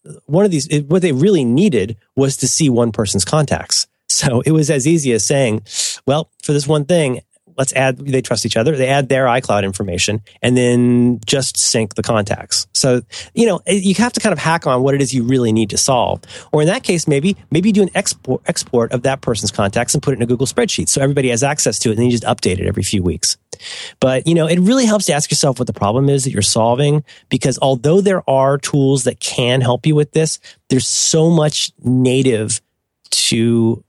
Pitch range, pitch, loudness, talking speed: 115-150 Hz, 130 Hz, -15 LUFS, 225 wpm